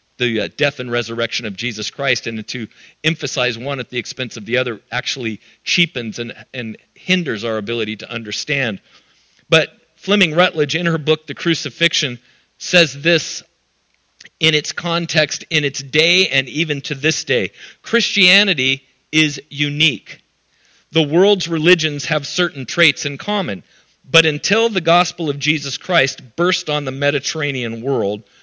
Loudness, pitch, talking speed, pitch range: -17 LUFS, 150 Hz, 150 wpm, 125-170 Hz